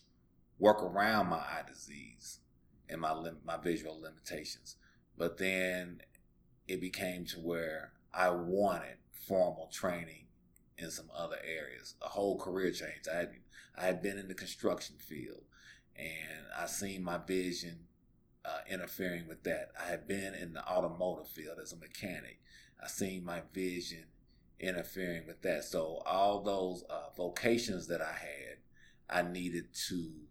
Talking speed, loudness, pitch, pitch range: 150 wpm, -38 LUFS, 85 Hz, 80-90 Hz